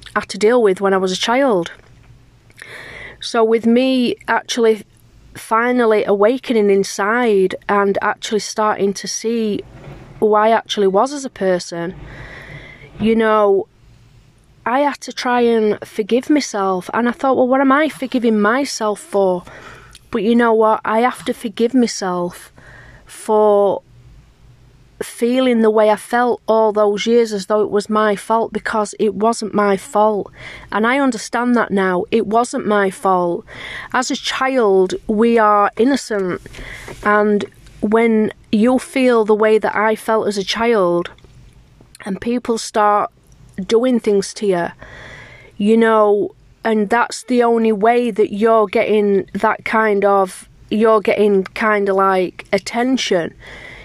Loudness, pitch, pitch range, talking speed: -16 LUFS, 210 Hz, 190-230 Hz, 150 wpm